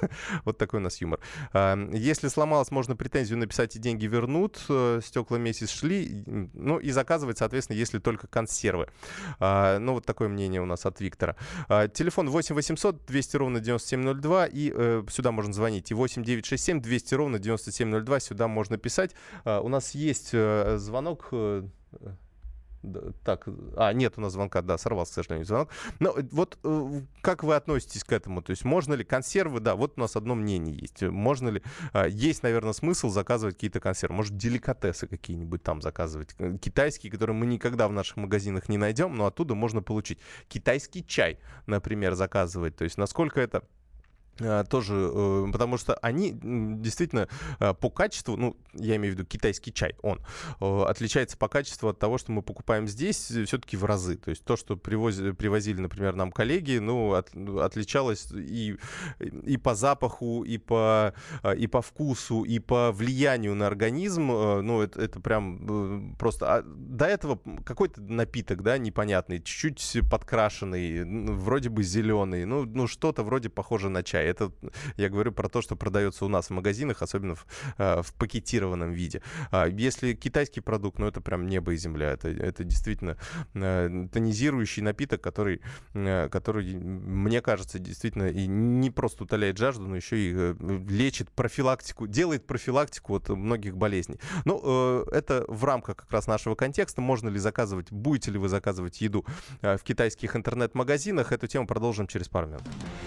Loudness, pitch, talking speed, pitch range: -29 LUFS, 110 Hz, 155 wpm, 100-130 Hz